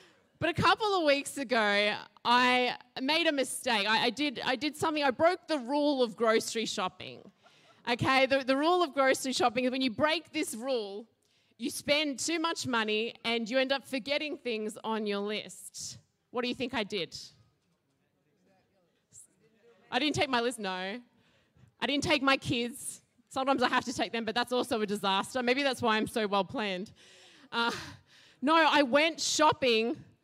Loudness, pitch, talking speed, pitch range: -29 LUFS, 250 Hz, 180 wpm, 225-285 Hz